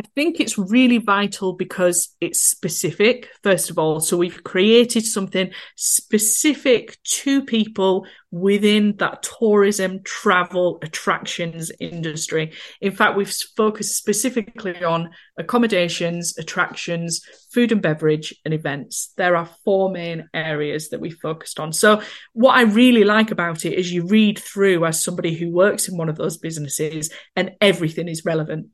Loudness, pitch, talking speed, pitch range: -19 LUFS, 185 Hz, 145 wpm, 170-215 Hz